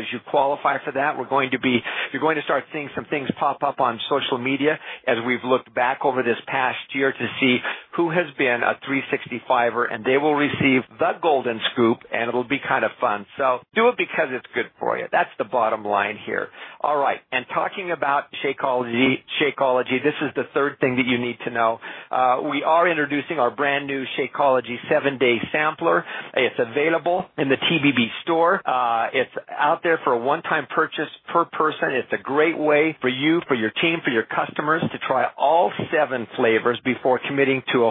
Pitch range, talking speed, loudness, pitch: 125-155 Hz, 205 wpm, -22 LUFS, 135 Hz